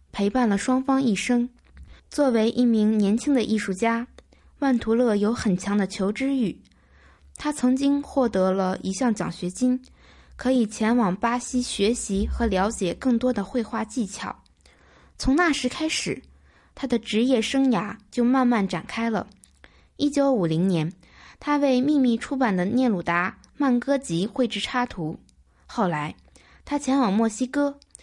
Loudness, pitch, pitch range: -24 LUFS, 235 Hz, 195-255 Hz